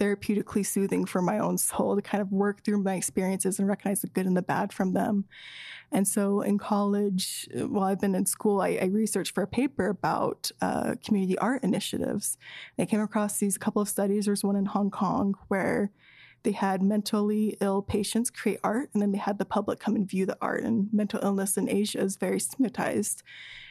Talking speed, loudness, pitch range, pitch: 210 wpm, -28 LUFS, 195-210 Hz, 205 Hz